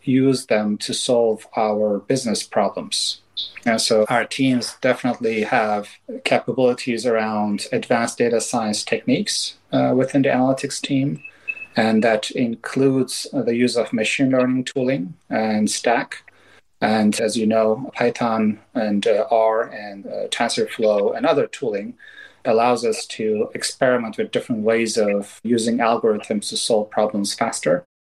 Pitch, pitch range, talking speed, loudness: 115 Hz, 105-130 Hz, 135 wpm, -20 LUFS